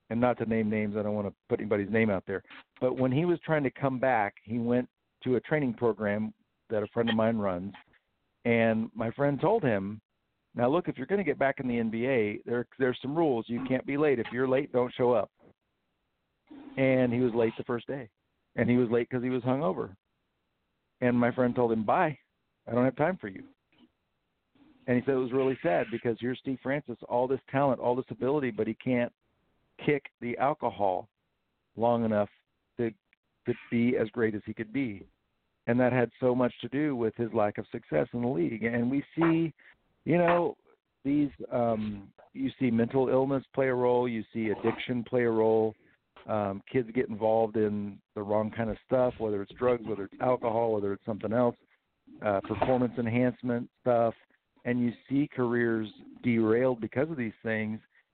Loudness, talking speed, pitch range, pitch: -29 LUFS, 200 wpm, 110-130 Hz, 120 Hz